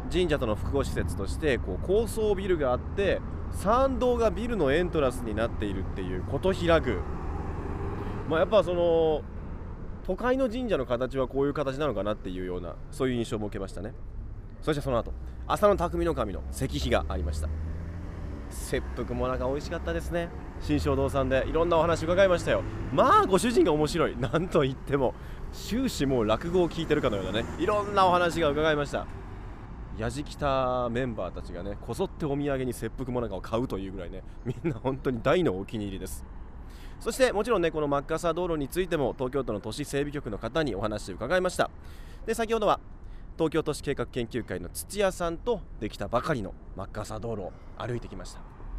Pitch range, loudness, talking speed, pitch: 95-160 Hz, -28 LUFS, 395 characters per minute, 125 Hz